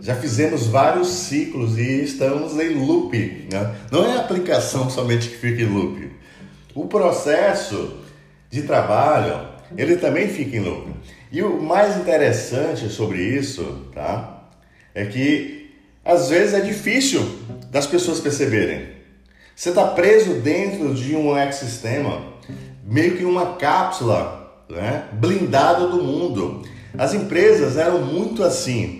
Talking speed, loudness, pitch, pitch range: 130 wpm, -20 LUFS, 140 Hz, 115-175 Hz